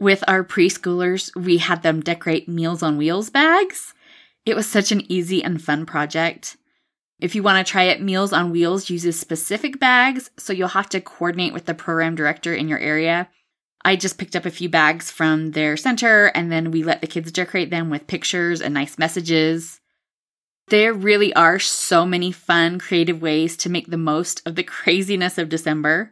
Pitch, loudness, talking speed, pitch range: 175 Hz, -19 LUFS, 190 wpm, 165-190 Hz